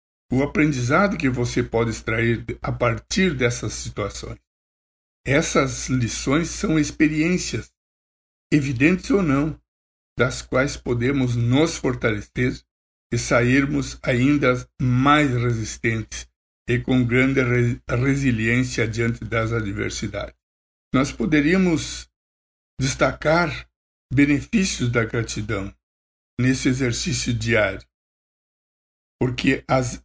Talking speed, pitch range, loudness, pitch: 90 wpm, 90-135 Hz, -21 LUFS, 120 Hz